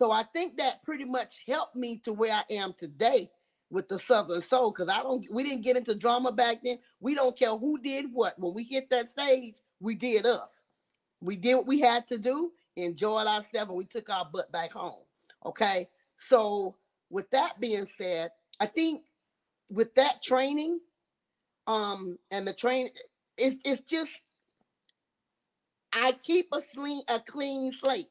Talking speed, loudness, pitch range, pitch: 175 wpm, -30 LUFS, 205-265 Hz, 240 Hz